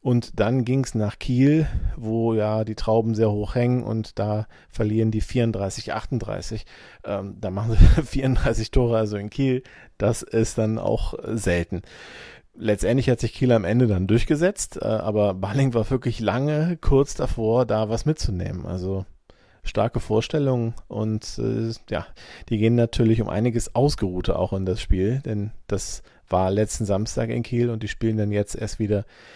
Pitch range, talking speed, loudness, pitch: 105-120 Hz, 160 wpm, -23 LUFS, 110 Hz